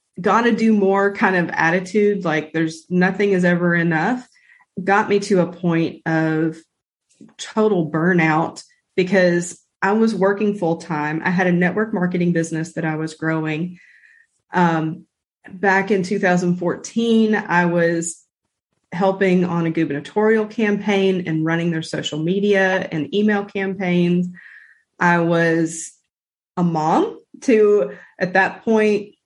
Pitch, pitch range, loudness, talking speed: 180 Hz, 165-205 Hz, -19 LUFS, 130 wpm